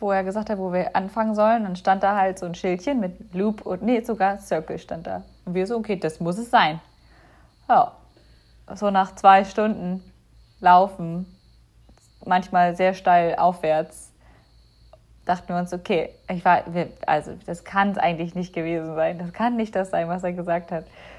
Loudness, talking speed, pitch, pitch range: -23 LUFS, 185 wpm, 185 Hz, 175-205 Hz